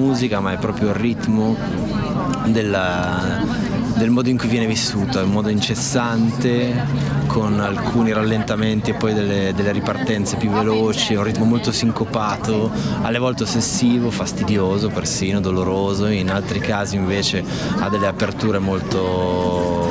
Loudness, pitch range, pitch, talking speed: -19 LUFS, 100-115 Hz, 105 Hz, 140 wpm